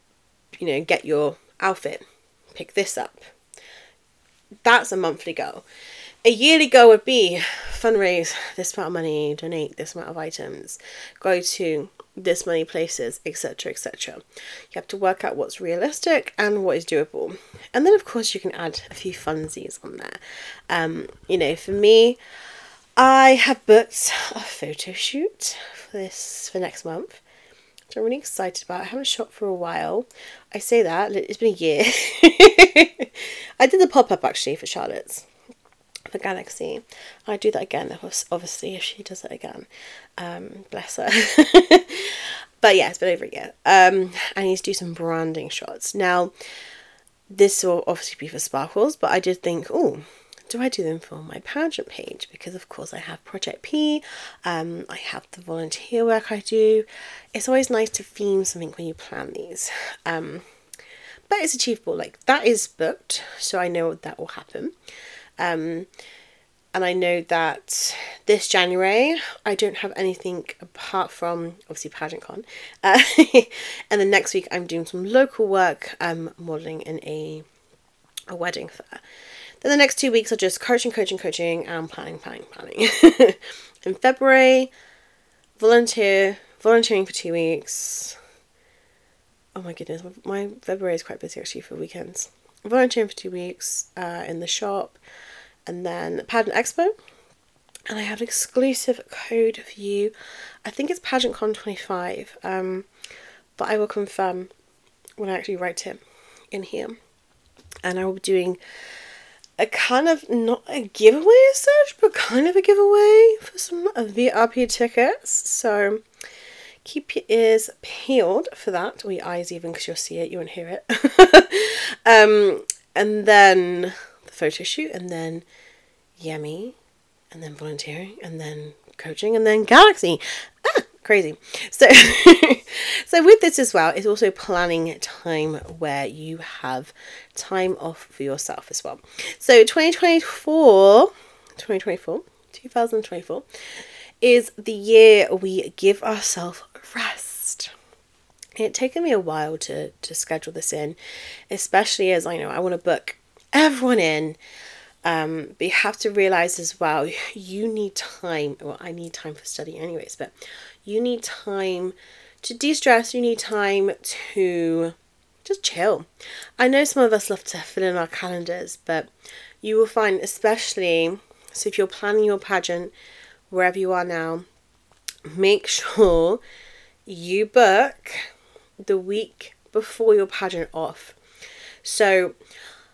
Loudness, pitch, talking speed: -19 LUFS, 215 Hz, 155 wpm